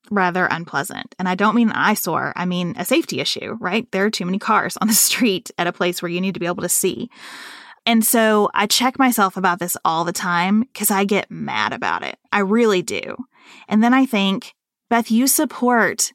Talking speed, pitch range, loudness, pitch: 215 wpm, 180-230 Hz, -18 LUFS, 205 Hz